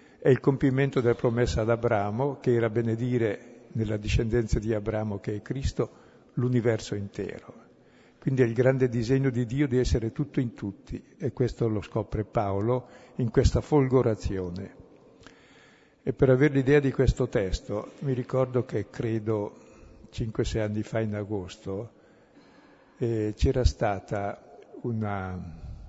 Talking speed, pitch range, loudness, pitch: 135 wpm, 105-130 Hz, -27 LUFS, 115 Hz